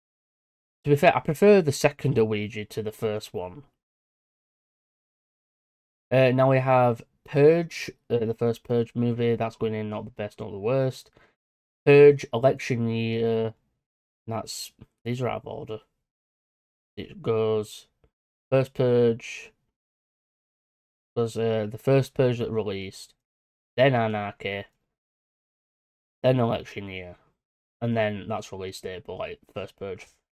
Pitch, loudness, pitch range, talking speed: 115 Hz, -24 LUFS, 110-130 Hz, 130 wpm